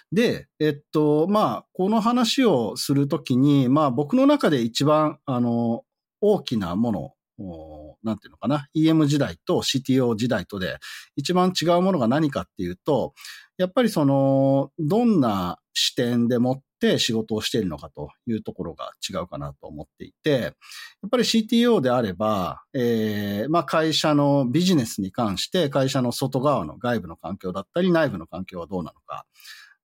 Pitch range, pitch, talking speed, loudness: 110-175 Hz, 140 Hz, 310 characters per minute, -22 LUFS